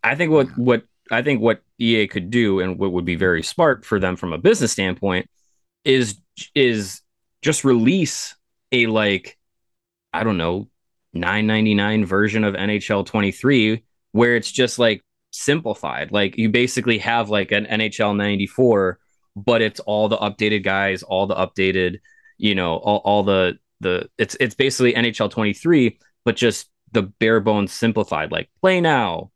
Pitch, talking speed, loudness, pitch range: 105 Hz, 160 wpm, -19 LUFS, 95-115 Hz